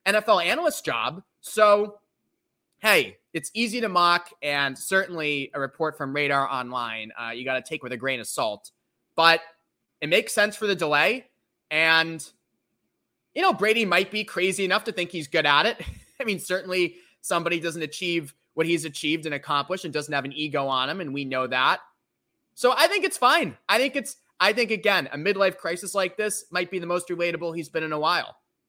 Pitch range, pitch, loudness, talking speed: 145-205 Hz, 170 Hz, -24 LUFS, 200 wpm